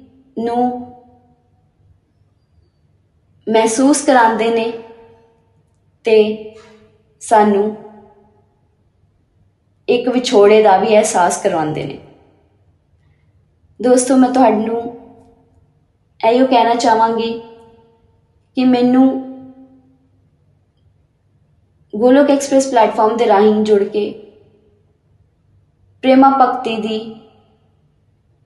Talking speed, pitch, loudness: 65 wpm, 220 Hz, -13 LUFS